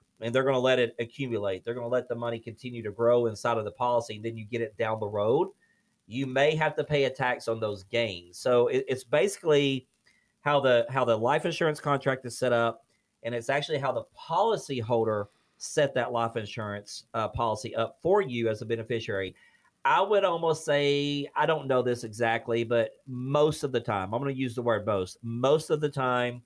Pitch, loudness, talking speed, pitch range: 120 Hz, -28 LUFS, 220 wpm, 115-140 Hz